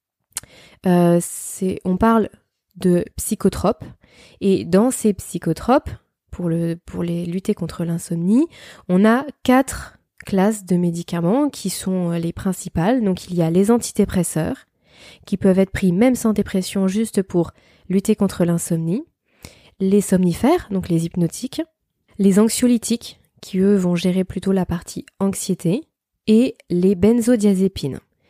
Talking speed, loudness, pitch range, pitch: 135 wpm, -19 LUFS, 175-220 Hz, 190 Hz